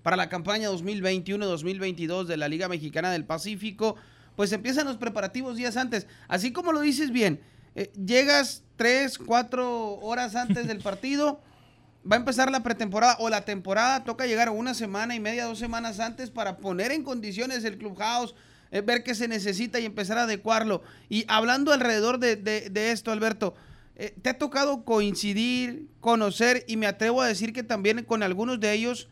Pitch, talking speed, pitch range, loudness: 225 Hz, 180 wpm, 205-245 Hz, -27 LUFS